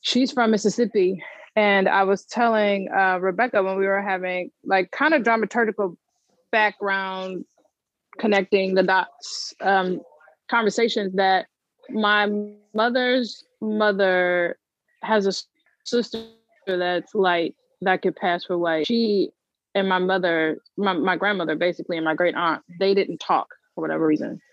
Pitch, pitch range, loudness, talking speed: 195 Hz, 185-225 Hz, -22 LUFS, 135 wpm